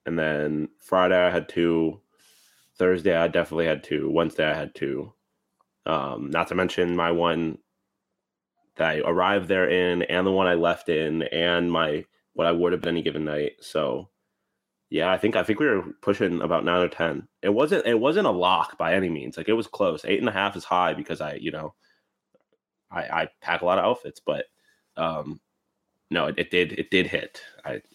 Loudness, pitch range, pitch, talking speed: -24 LUFS, 80-90 Hz, 85 Hz, 205 wpm